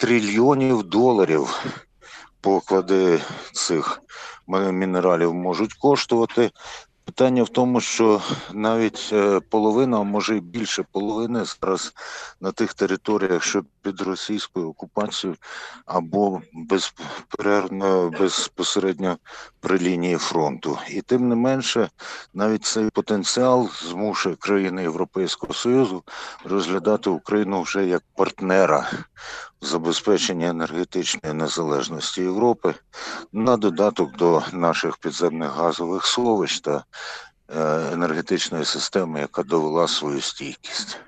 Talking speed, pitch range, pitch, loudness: 100 wpm, 90-110 Hz, 100 Hz, -22 LUFS